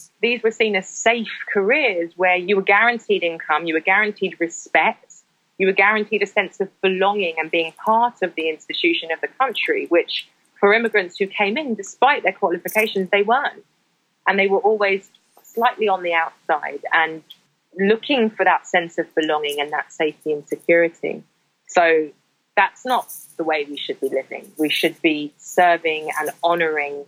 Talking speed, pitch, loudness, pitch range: 170 wpm, 185 Hz, -19 LUFS, 165-205 Hz